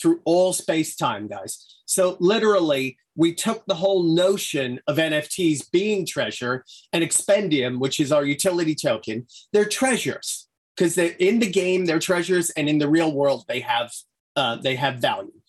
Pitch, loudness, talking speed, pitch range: 165 Hz, -22 LUFS, 165 wpm, 150-190 Hz